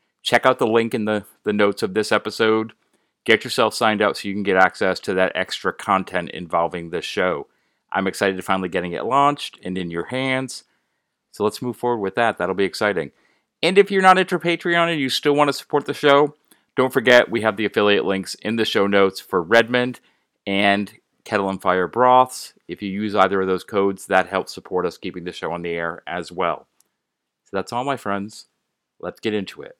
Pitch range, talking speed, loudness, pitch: 95-130 Hz, 215 wpm, -20 LUFS, 105 Hz